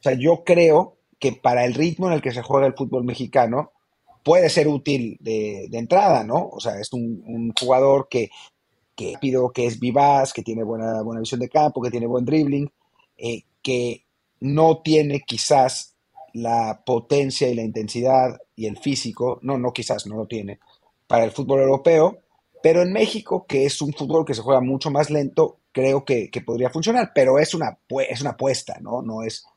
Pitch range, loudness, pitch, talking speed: 115-145 Hz, -21 LUFS, 130 Hz, 195 wpm